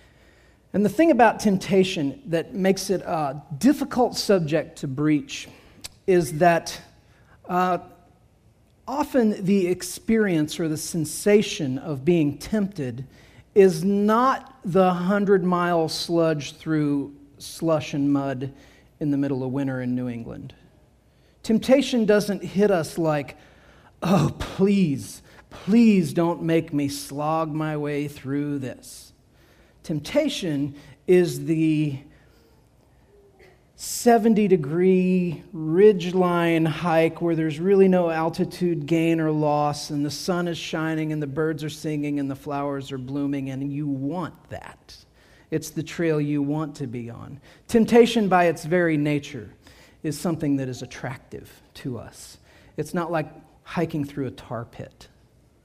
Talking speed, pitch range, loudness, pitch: 130 wpm, 145-185 Hz, -23 LUFS, 160 Hz